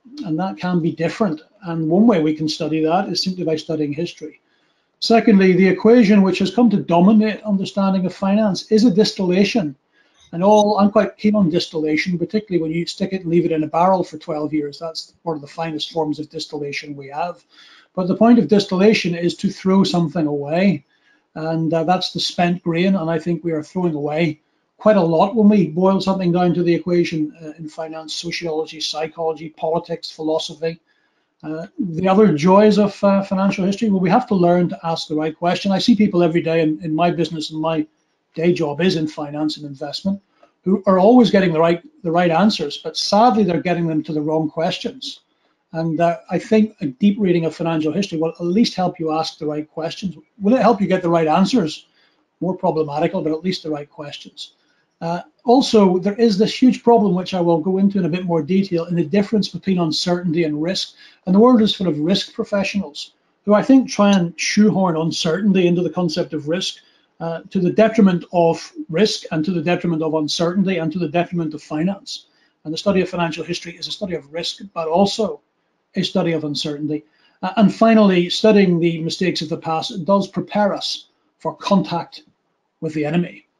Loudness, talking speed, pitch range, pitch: -18 LUFS, 205 wpm, 160-195 Hz, 175 Hz